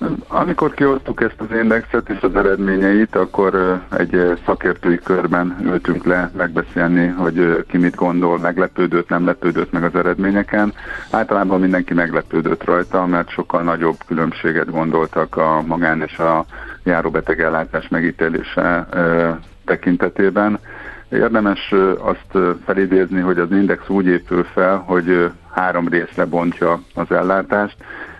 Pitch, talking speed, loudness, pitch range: 90 Hz, 120 wpm, -17 LUFS, 85-100 Hz